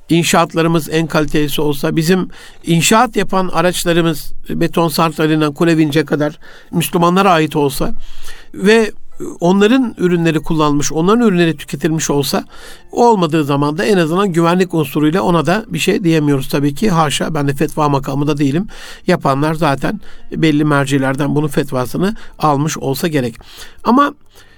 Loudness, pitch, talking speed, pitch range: -14 LUFS, 165 Hz, 130 wpm, 150-180 Hz